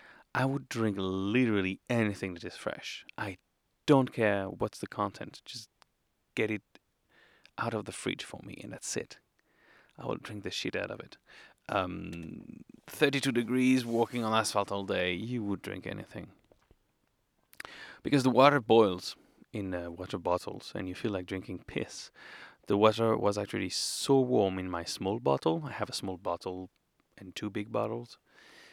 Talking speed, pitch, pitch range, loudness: 165 wpm, 105 Hz, 95-125 Hz, -31 LUFS